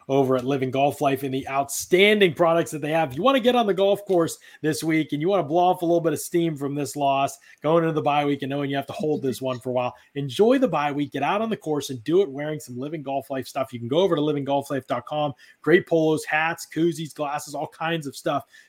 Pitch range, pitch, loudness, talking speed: 140-170 Hz, 150 Hz, -23 LUFS, 275 wpm